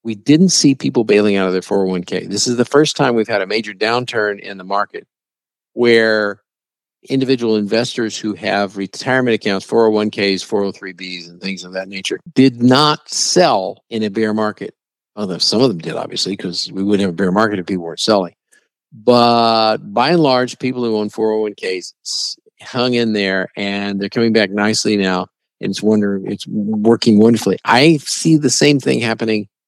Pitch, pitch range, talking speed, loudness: 110 Hz, 100-120 Hz, 180 wpm, -15 LUFS